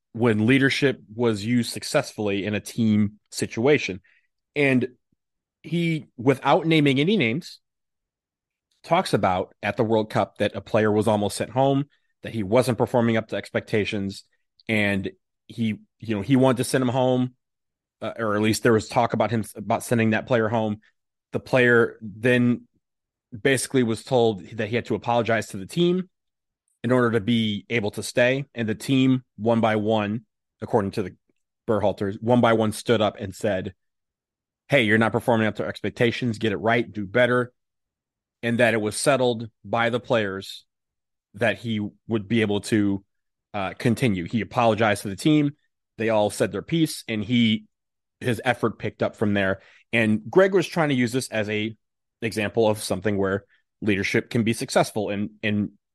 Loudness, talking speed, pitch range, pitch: -23 LUFS, 175 wpm, 105-125 Hz, 115 Hz